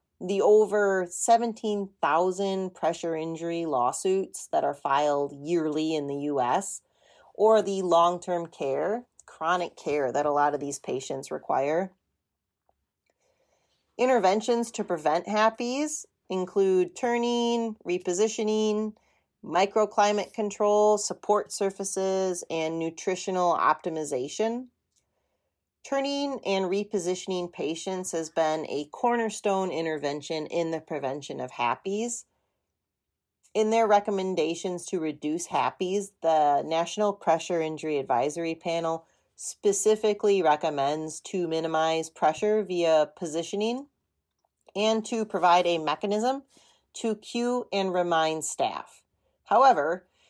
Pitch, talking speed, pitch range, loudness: 185 Hz, 100 wpm, 160-215 Hz, -27 LUFS